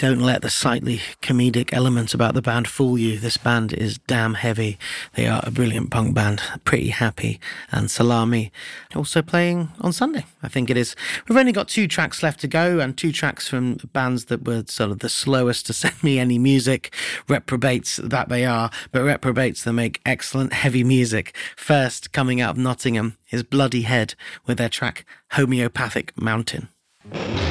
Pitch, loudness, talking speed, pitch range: 125 Hz, -21 LUFS, 180 wpm, 115-135 Hz